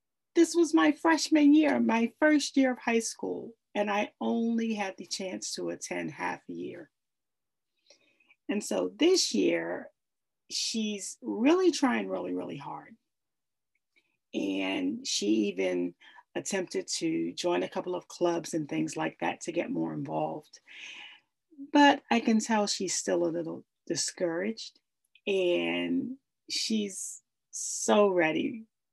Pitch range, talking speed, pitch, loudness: 175-275 Hz, 130 wpm, 215 Hz, -29 LUFS